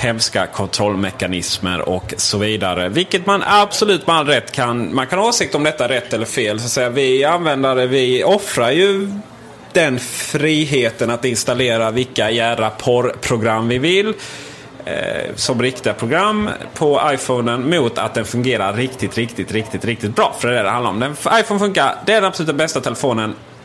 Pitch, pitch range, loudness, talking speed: 125 Hz, 110-165 Hz, -16 LUFS, 175 wpm